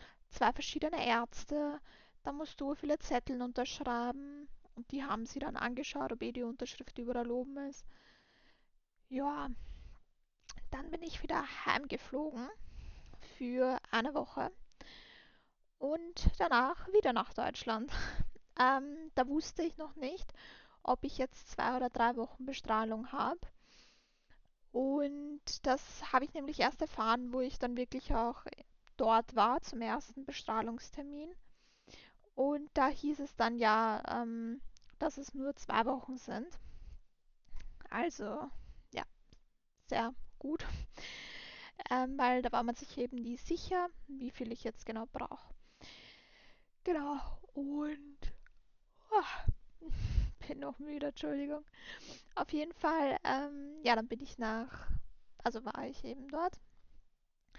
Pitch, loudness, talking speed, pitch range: 270 Hz, -37 LUFS, 125 wpm, 240-295 Hz